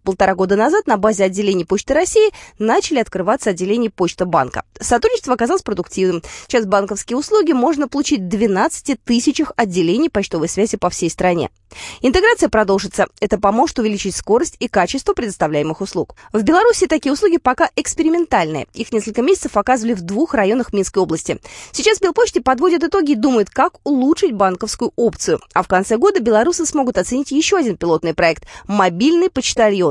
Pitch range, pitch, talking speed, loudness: 195-315 Hz, 230 Hz, 155 wpm, -16 LUFS